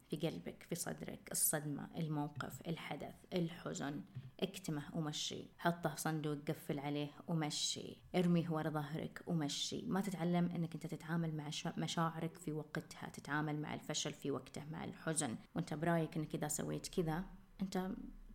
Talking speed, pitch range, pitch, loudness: 140 wpm, 150-175 Hz, 160 Hz, -41 LUFS